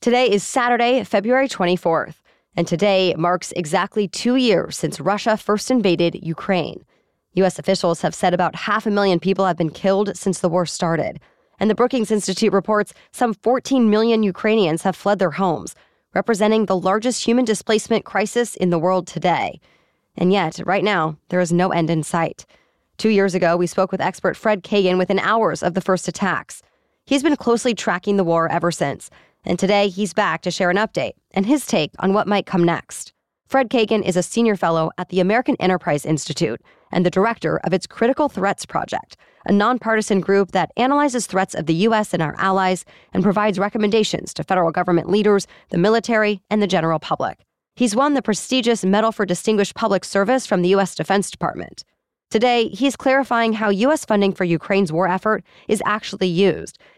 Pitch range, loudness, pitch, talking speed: 180-220 Hz, -19 LUFS, 195 Hz, 185 wpm